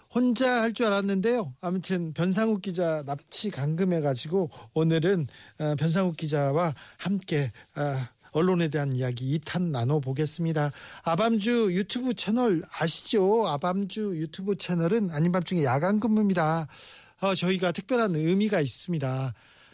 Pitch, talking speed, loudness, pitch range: 175 Hz, 300 characters per minute, -27 LUFS, 150-200 Hz